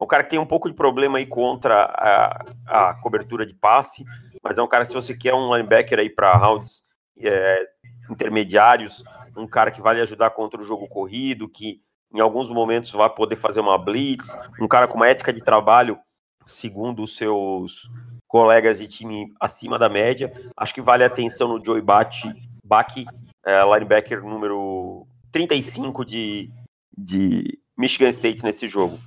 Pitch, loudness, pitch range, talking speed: 115 Hz, -19 LUFS, 110-125 Hz, 165 wpm